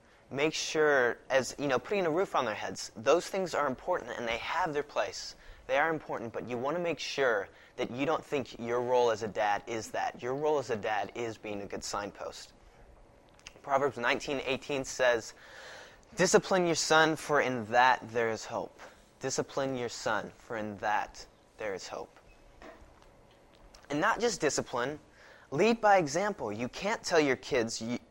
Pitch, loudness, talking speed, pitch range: 130 Hz, -31 LUFS, 180 wpm, 115-155 Hz